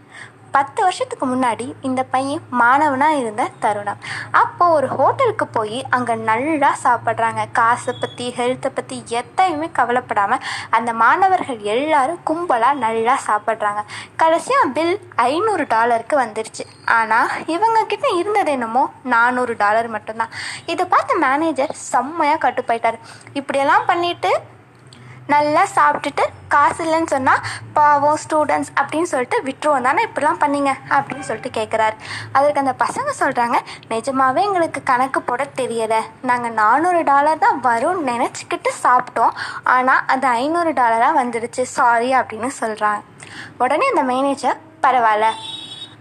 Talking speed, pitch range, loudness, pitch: 115 wpm, 235-310 Hz, -18 LUFS, 265 Hz